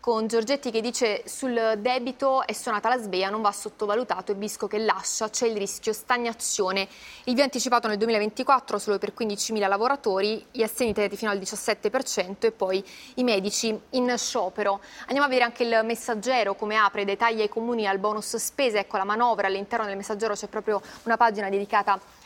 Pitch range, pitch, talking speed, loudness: 205-235 Hz, 220 Hz, 185 wpm, -26 LUFS